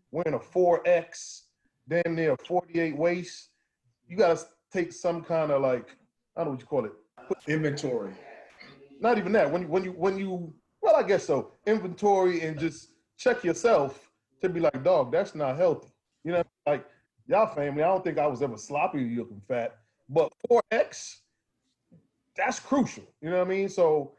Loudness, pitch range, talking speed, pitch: -27 LUFS, 145-185 Hz, 180 wpm, 170 Hz